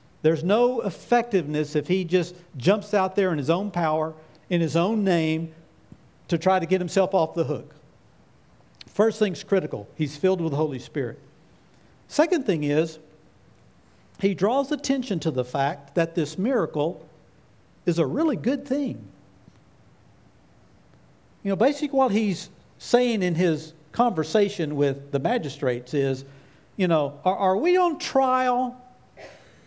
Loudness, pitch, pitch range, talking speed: -24 LUFS, 180 Hz, 155-215 Hz, 145 wpm